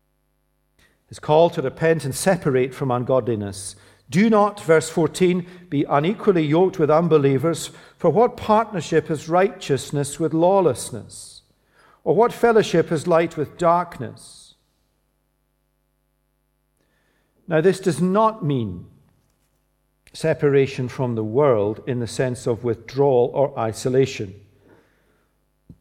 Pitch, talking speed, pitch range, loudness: 140 Hz, 110 wpm, 130-170 Hz, -20 LUFS